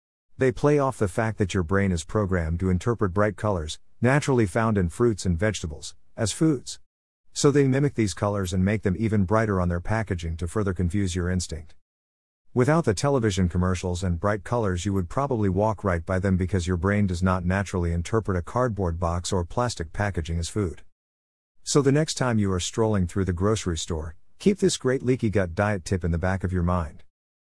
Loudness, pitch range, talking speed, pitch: -25 LUFS, 90-110 Hz, 205 wpm, 95 Hz